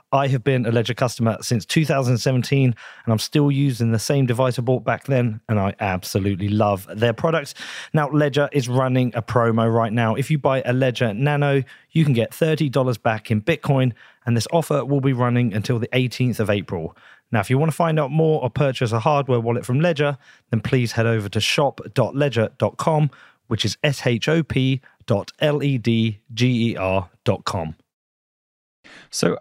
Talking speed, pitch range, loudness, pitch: 190 wpm, 115-140 Hz, -21 LUFS, 125 Hz